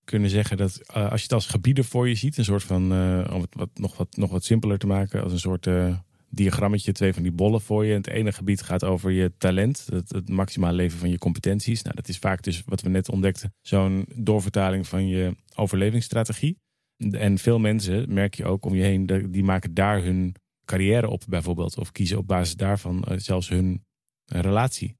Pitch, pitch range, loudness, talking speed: 95 Hz, 95-105 Hz, -24 LUFS, 220 wpm